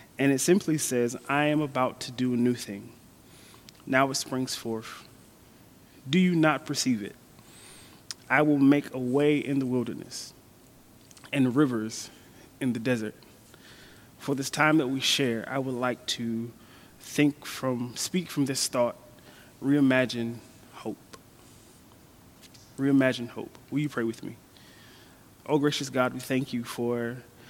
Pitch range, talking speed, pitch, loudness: 120-140 Hz, 145 wpm, 130 Hz, -27 LUFS